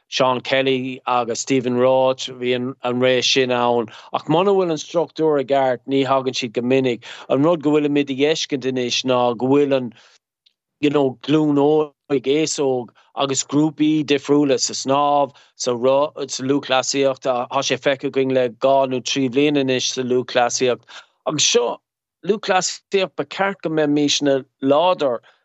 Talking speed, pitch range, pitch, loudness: 135 wpm, 130-145 Hz, 135 Hz, -19 LUFS